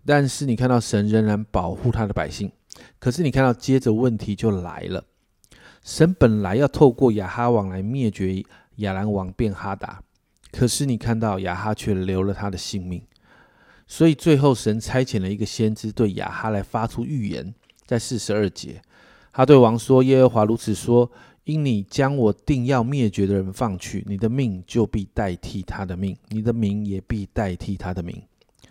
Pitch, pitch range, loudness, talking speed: 110 Hz, 100-125 Hz, -22 LUFS, 260 characters per minute